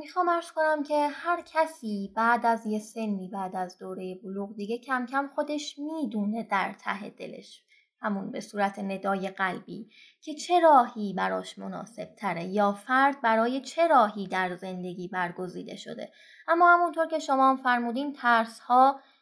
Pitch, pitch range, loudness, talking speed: 230 Hz, 195-295 Hz, -27 LUFS, 155 wpm